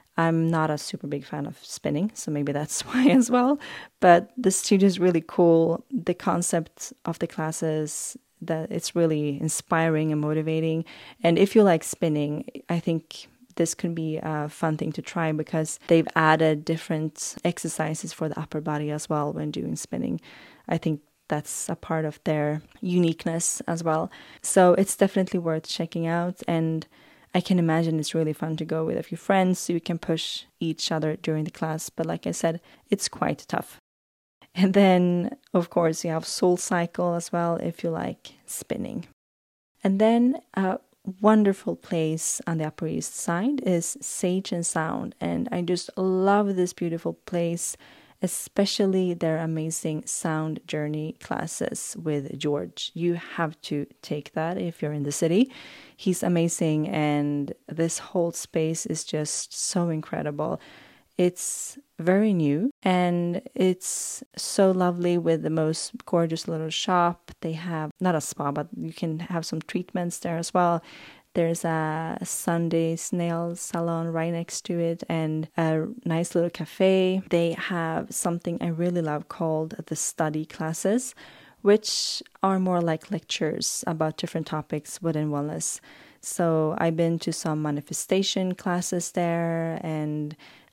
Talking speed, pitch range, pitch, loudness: 155 wpm, 155-180 Hz, 165 Hz, -26 LUFS